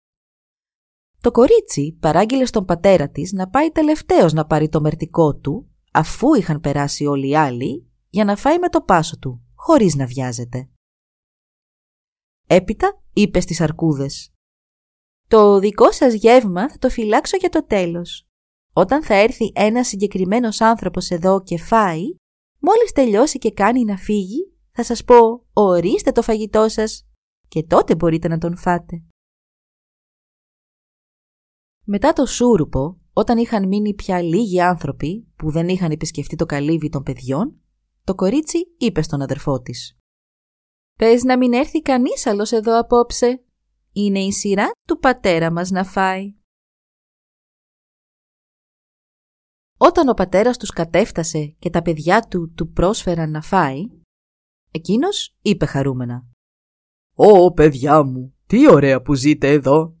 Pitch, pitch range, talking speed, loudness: 185 Hz, 155-230 Hz, 135 wpm, -17 LUFS